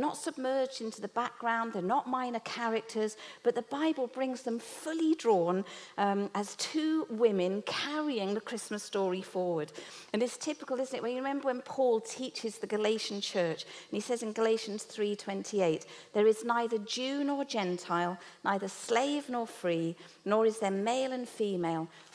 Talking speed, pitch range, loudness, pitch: 165 wpm, 200-255 Hz, -33 LUFS, 225 Hz